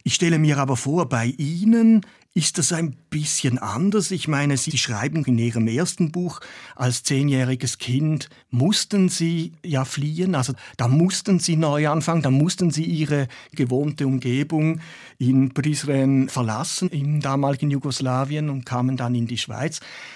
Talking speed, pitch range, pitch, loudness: 150 wpm, 130-165 Hz, 145 Hz, -22 LUFS